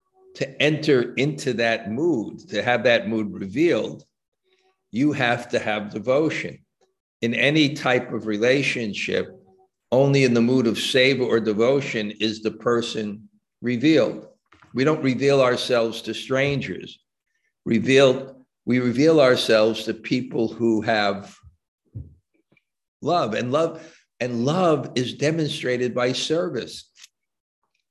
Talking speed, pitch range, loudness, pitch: 120 wpm, 115-145 Hz, -22 LUFS, 125 Hz